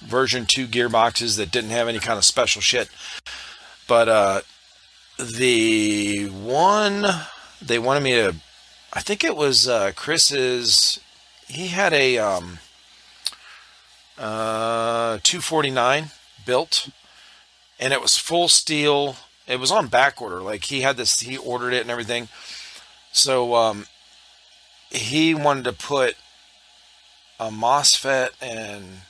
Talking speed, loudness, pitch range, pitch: 130 wpm, -19 LUFS, 110-140 Hz, 120 Hz